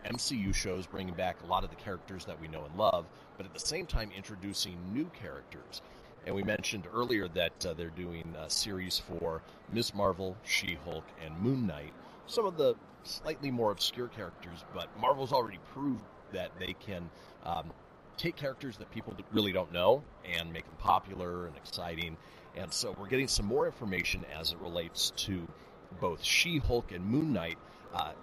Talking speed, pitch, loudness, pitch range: 180 wpm, 95 Hz, -35 LUFS, 90-110 Hz